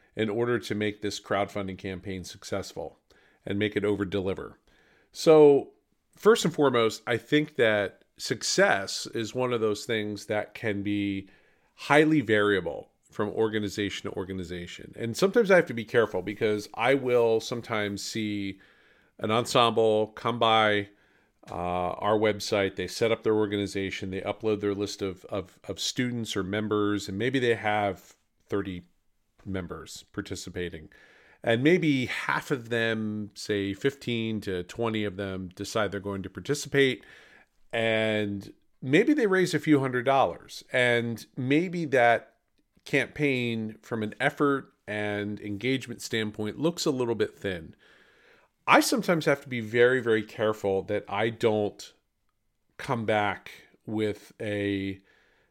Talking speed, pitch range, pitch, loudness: 140 wpm, 100-125 Hz, 110 Hz, -27 LUFS